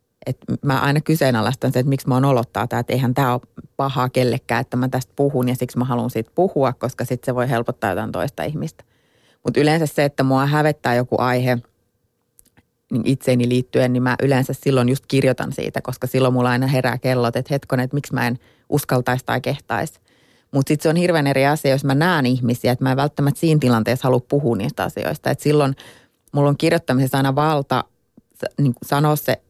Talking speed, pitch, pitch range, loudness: 200 wpm, 130 Hz, 125-140 Hz, -19 LUFS